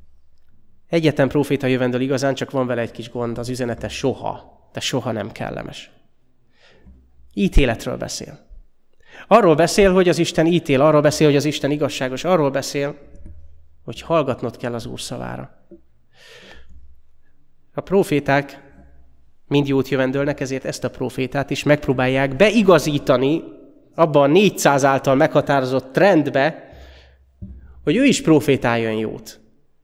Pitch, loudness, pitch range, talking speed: 135 Hz, -18 LUFS, 95-145 Hz, 125 wpm